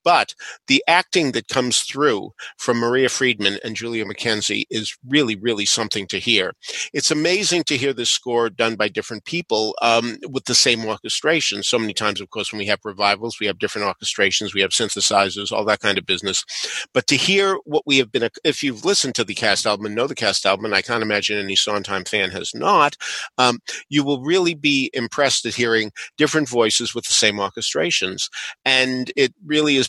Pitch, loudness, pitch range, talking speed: 115 Hz, -19 LUFS, 105-135 Hz, 200 wpm